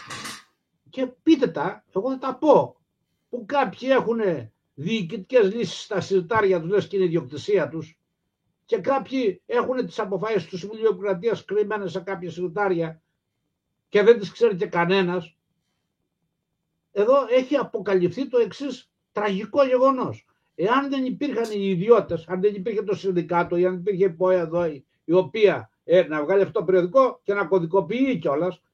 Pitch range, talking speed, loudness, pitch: 180-240 Hz, 150 wpm, -23 LUFS, 200 Hz